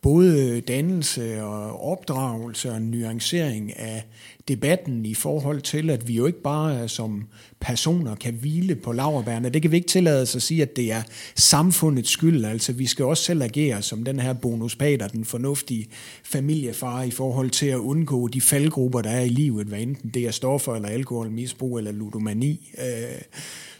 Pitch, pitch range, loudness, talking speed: 125 Hz, 115-145 Hz, -23 LUFS, 170 wpm